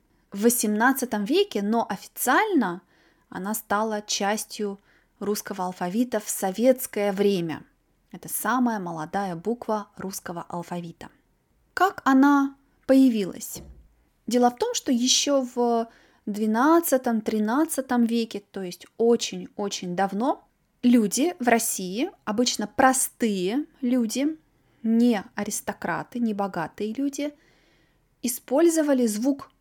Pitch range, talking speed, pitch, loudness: 200-265 Hz, 95 wpm, 230 Hz, -24 LUFS